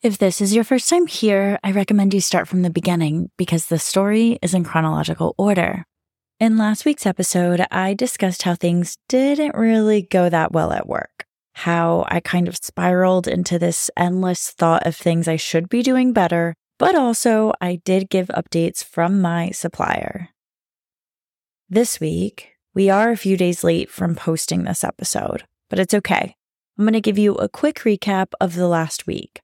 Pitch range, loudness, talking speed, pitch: 170-215 Hz, -19 LUFS, 180 wpm, 185 Hz